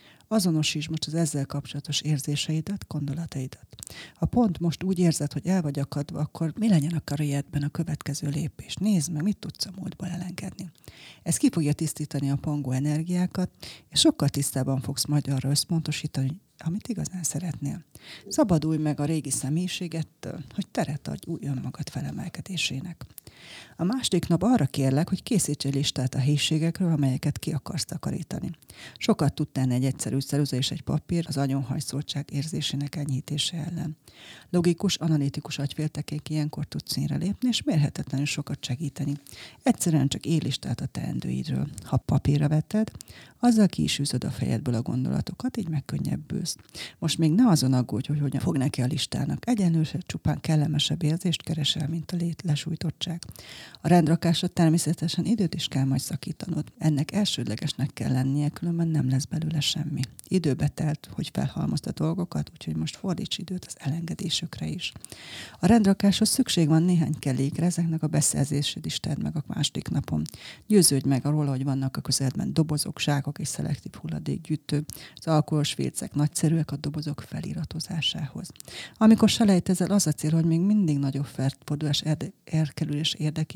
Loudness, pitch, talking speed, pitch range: -26 LUFS, 155 Hz, 150 wpm, 140-170 Hz